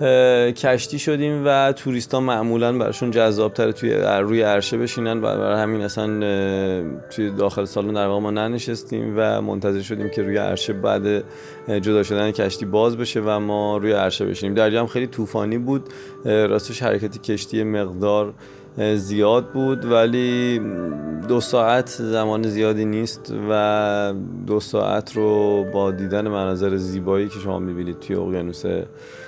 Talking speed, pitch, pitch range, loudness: 140 wpm, 105 Hz, 100-115 Hz, -21 LUFS